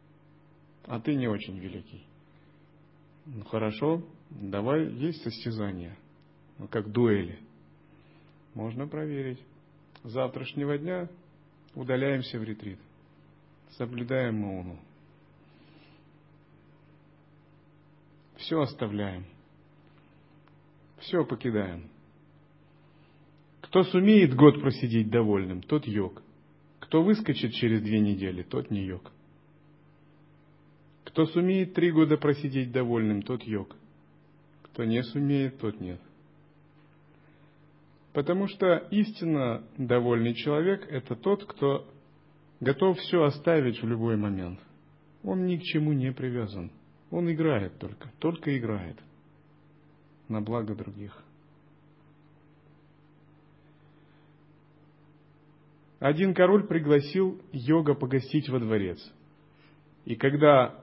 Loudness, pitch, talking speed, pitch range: -28 LUFS, 145 Hz, 90 wpm, 115-150 Hz